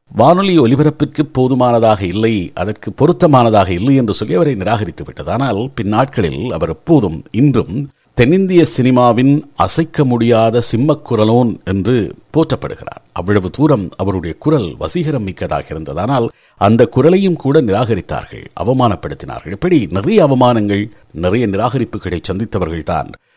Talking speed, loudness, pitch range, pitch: 110 wpm, -14 LUFS, 105-140 Hz, 120 Hz